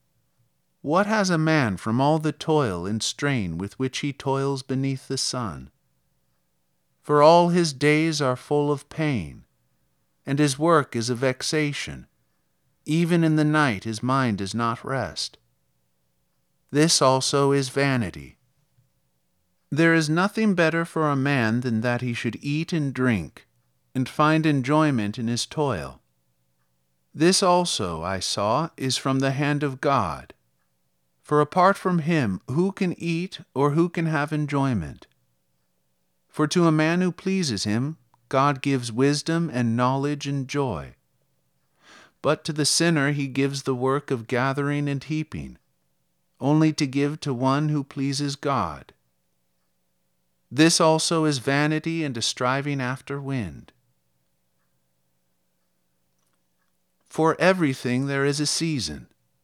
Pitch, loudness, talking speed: 135 Hz, -23 LUFS, 135 wpm